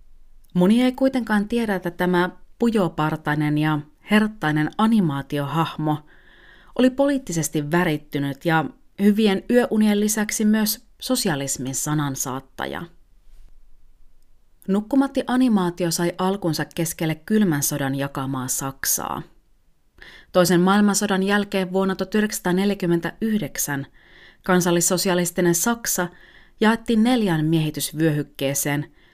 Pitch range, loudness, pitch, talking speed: 150-210 Hz, -21 LUFS, 175 Hz, 80 wpm